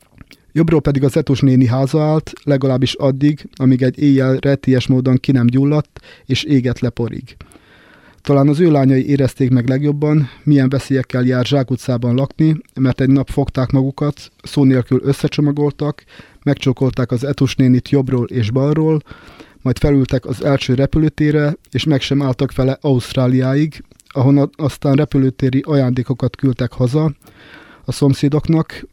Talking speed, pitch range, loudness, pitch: 135 wpm, 130-145 Hz, -15 LUFS, 135 Hz